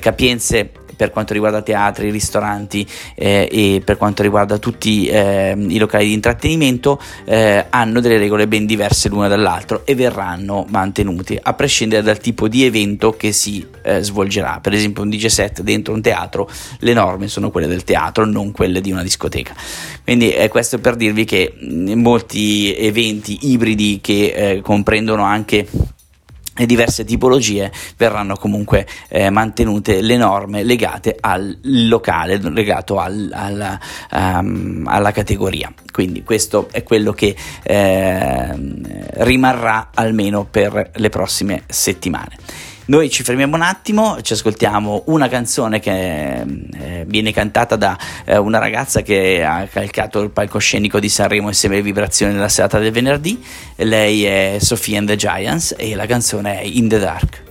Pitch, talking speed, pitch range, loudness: 105 Hz, 150 wpm, 100-115 Hz, -15 LUFS